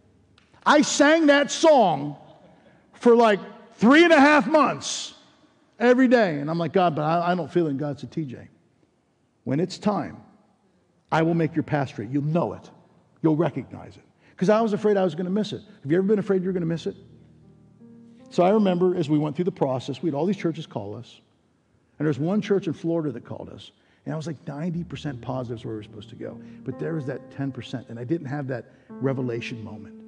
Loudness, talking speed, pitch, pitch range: -23 LUFS, 225 wpm, 160 Hz, 130-195 Hz